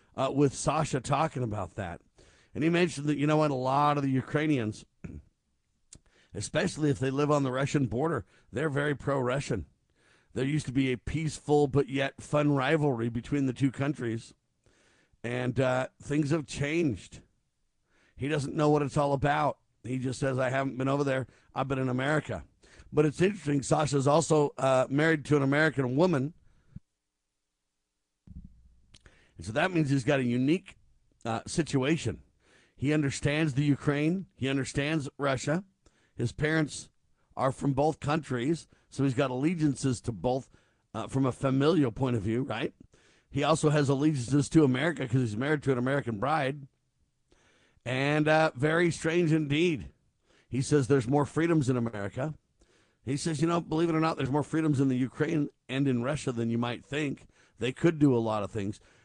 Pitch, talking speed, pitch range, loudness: 140 Hz, 170 wpm, 125-150 Hz, -29 LUFS